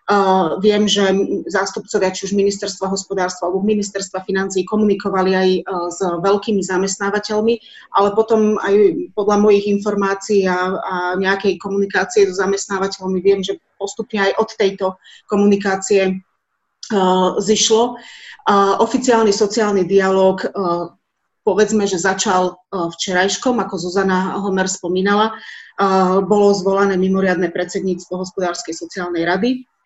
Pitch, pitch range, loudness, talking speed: 195 Hz, 185-205 Hz, -17 LUFS, 105 wpm